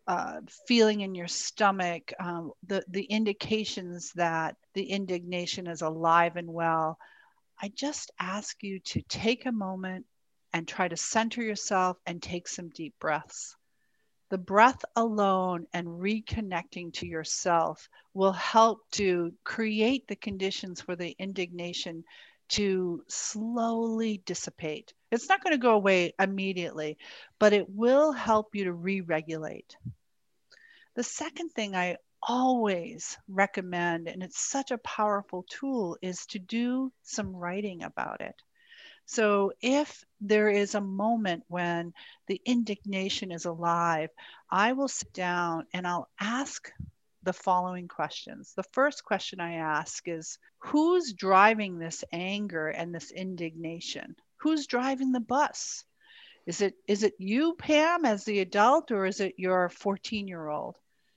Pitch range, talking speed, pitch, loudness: 175-230 Hz, 140 wpm, 195 Hz, -29 LUFS